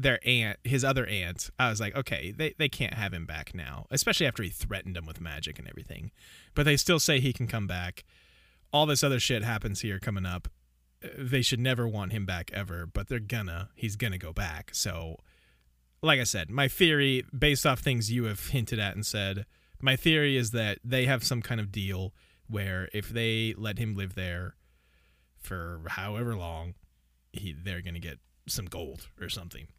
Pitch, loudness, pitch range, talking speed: 105 Hz, -29 LUFS, 90-125 Hz, 195 wpm